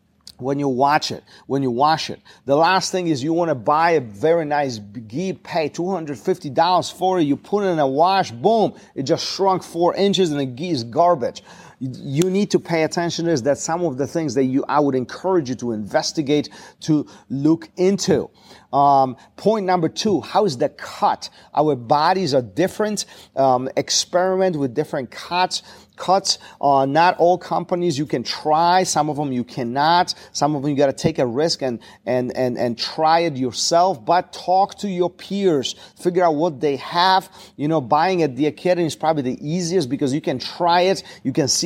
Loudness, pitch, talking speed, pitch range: -20 LUFS, 160 Hz, 195 wpm, 140-180 Hz